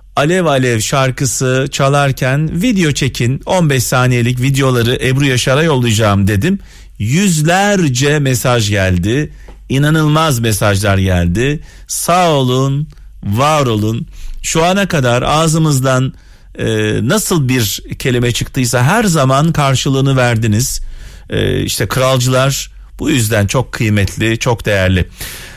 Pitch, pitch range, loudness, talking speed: 130 Hz, 115-150 Hz, -13 LUFS, 105 wpm